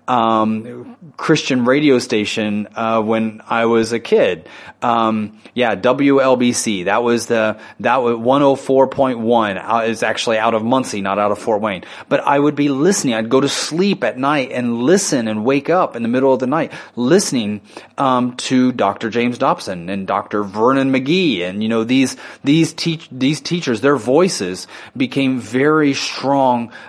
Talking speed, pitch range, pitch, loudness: 165 wpm, 110-135 Hz, 125 Hz, -16 LUFS